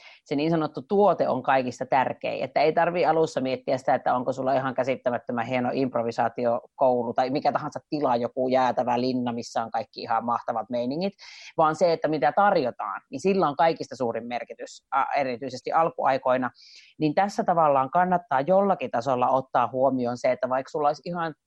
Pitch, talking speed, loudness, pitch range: 135 Hz, 170 wpm, -25 LUFS, 125-165 Hz